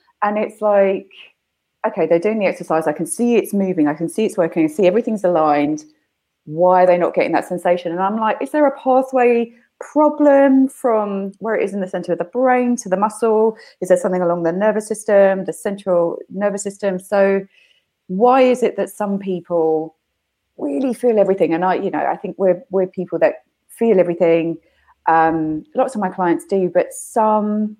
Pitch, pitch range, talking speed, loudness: 195 Hz, 175-220 Hz, 195 wpm, -17 LUFS